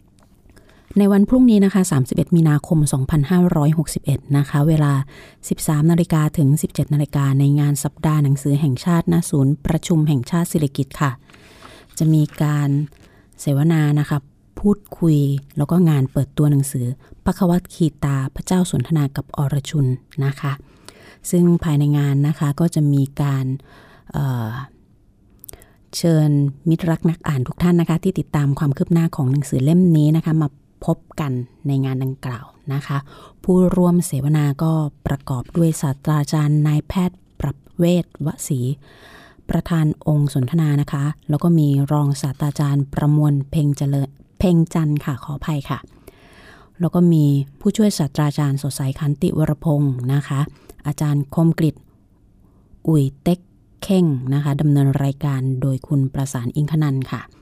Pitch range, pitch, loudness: 140-160 Hz, 145 Hz, -19 LUFS